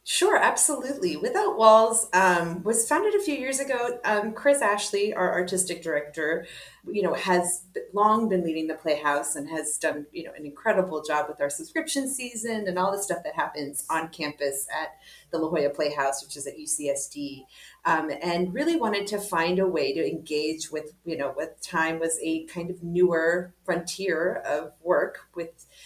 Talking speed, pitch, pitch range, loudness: 180 wpm, 175 Hz, 155-215 Hz, -26 LUFS